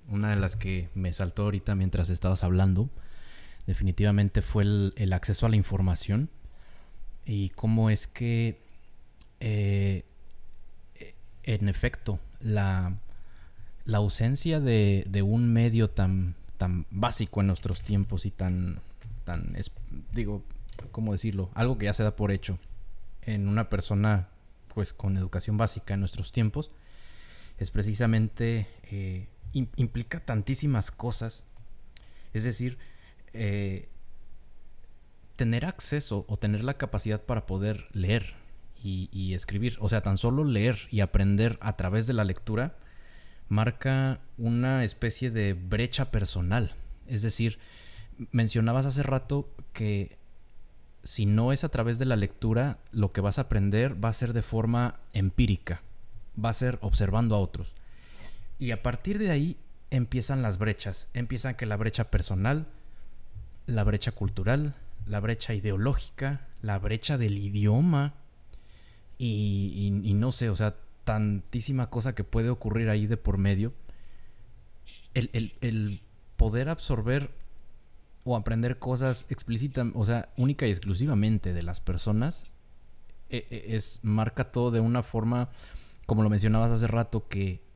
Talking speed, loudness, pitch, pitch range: 135 wpm, -29 LUFS, 110 Hz, 100-120 Hz